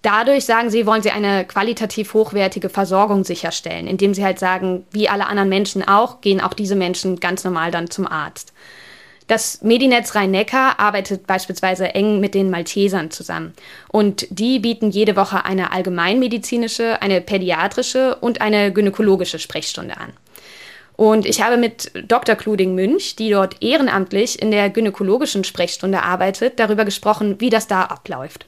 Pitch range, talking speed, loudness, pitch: 190-220 Hz, 155 wpm, -17 LUFS, 200 Hz